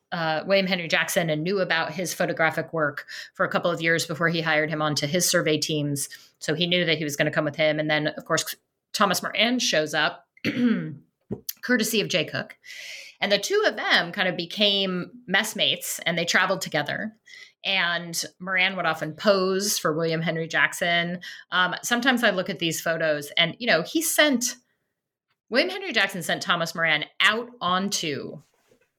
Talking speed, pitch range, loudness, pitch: 180 wpm, 160-205 Hz, -23 LUFS, 180 Hz